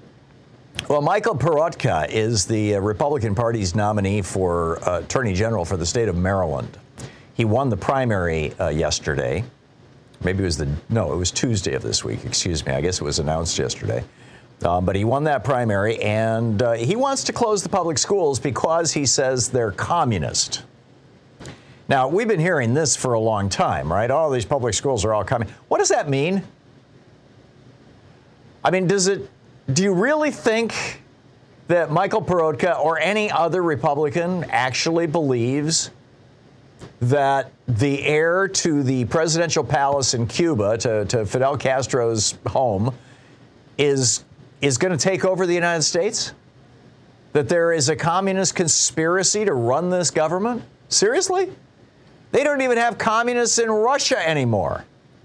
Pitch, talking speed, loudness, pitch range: 135 Hz, 155 wpm, -20 LUFS, 115-170 Hz